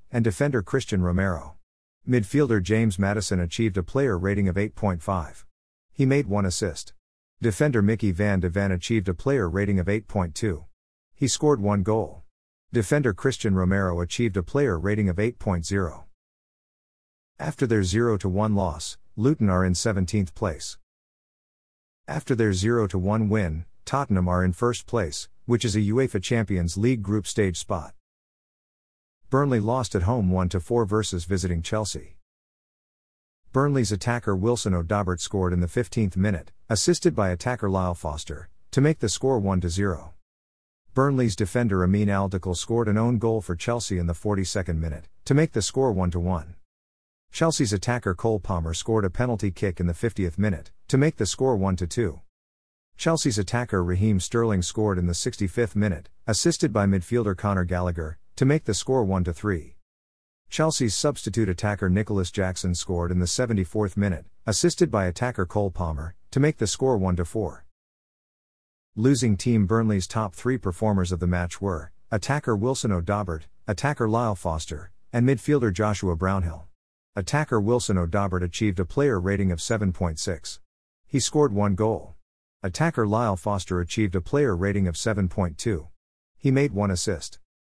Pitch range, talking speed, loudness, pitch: 90-115 Hz, 150 wpm, -25 LUFS, 100 Hz